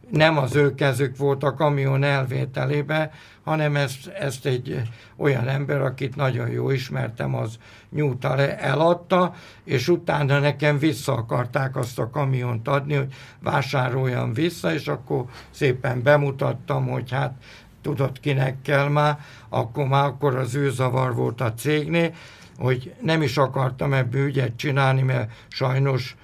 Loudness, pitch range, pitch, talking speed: -23 LUFS, 130-145 Hz, 135 Hz, 140 wpm